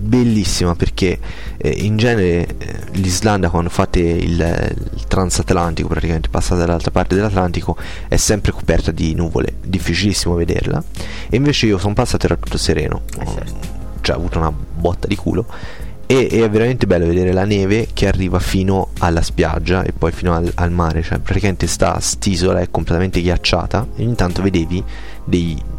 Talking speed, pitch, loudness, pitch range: 160 wpm, 90 Hz, -17 LUFS, 85-100 Hz